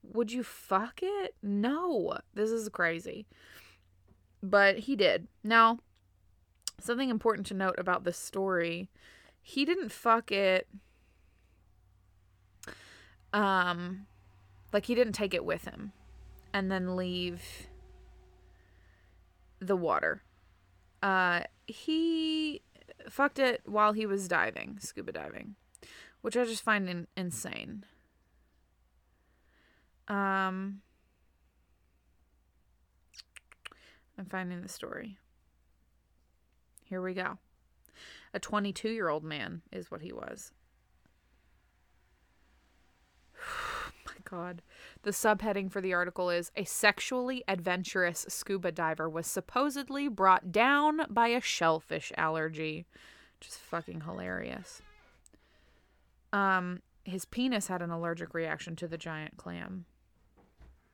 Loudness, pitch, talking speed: -32 LUFS, 175 Hz, 100 wpm